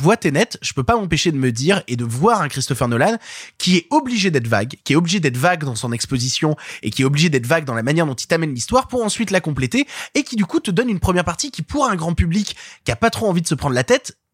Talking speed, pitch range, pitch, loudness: 290 wpm, 135-205 Hz, 165 Hz, -18 LUFS